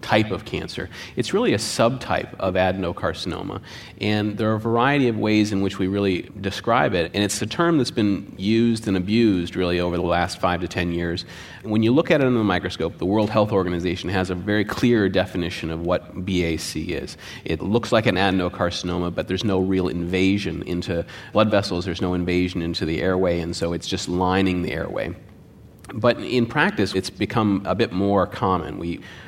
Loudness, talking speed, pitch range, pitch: -22 LUFS, 195 wpm, 90-105 Hz, 95 Hz